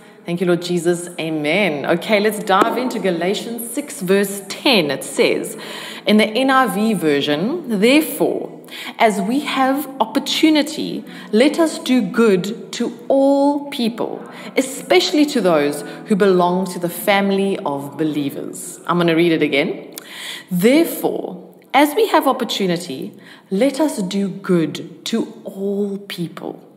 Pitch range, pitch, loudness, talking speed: 175-255 Hz, 205 Hz, -18 LUFS, 130 wpm